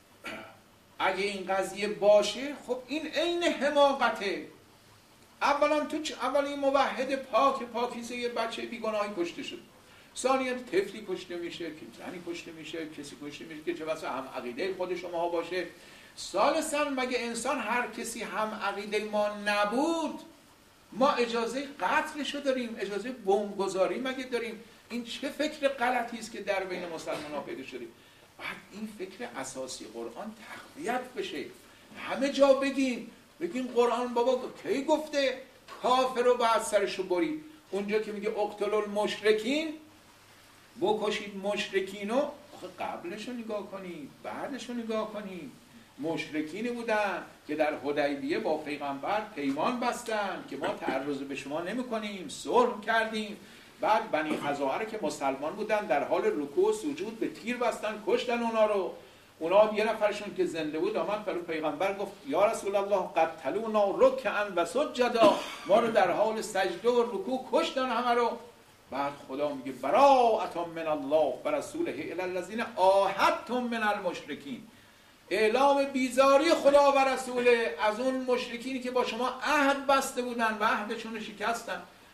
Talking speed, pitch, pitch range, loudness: 145 wpm, 225 Hz, 190-260 Hz, -30 LUFS